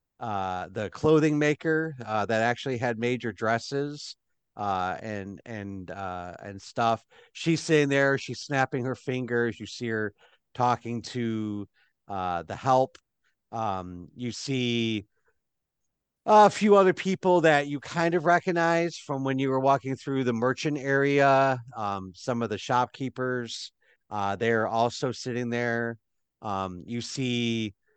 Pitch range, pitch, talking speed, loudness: 110-140 Hz, 120 Hz, 140 wpm, -27 LUFS